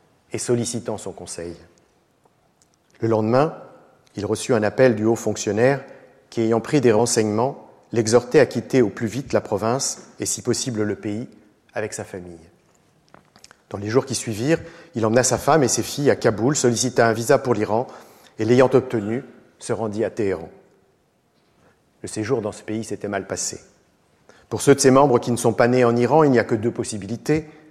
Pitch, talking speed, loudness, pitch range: 115 Hz, 185 wpm, -20 LUFS, 110-130 Hz